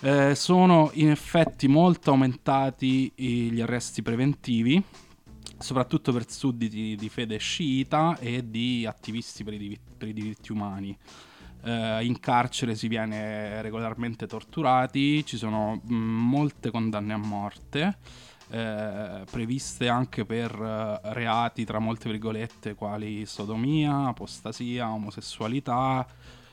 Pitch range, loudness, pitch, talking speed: 110-130 Hz, -27 LUFS, 115 Hz, 115 wpm